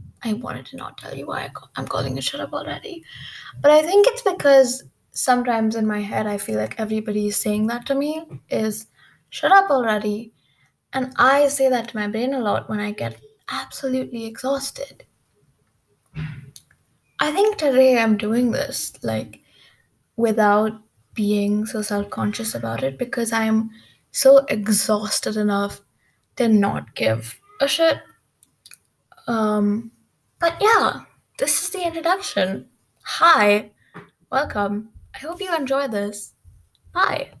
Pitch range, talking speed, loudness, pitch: 205-275 Hz, 140 wpm, -20 LUFS, 220 Hz